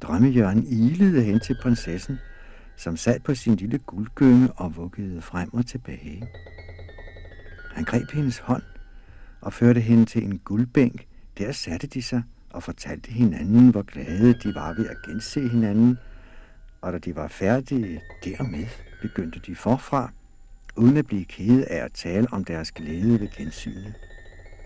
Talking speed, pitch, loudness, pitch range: 150 wpm, 110 Hz, -23 LUFS, 90-120 Hz